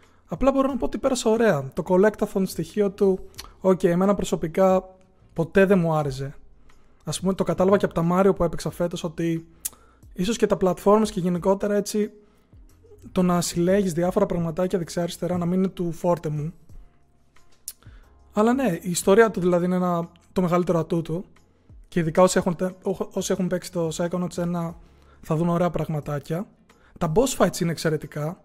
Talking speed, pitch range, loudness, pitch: 170 wpm, 170-195 Hz, -23 LUFS, 180 Hz